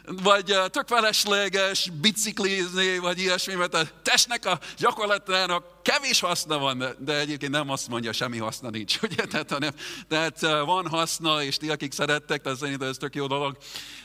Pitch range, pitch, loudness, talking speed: 145-195 Hz, 175 Hz, -25 LUFS, 160 wpm